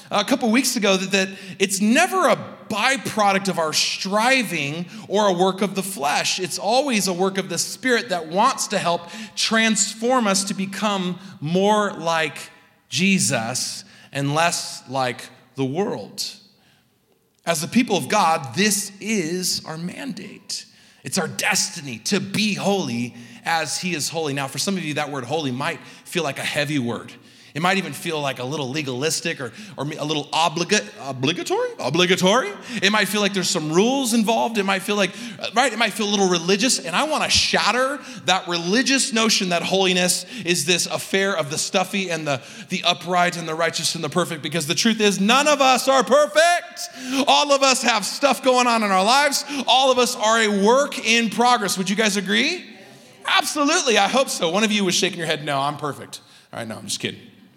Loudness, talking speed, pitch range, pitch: -20 LUFS, 195 wpm, 170-225 Hz, 195 Hz